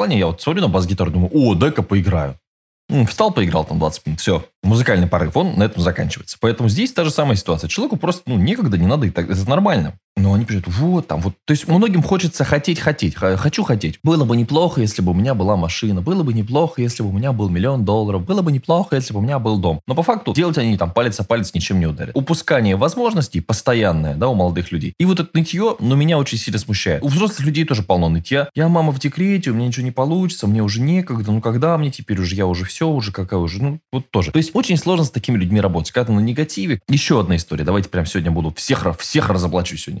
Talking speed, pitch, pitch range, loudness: 245 wpm, 115 Hz, 95-155 Hz, -18 LUFS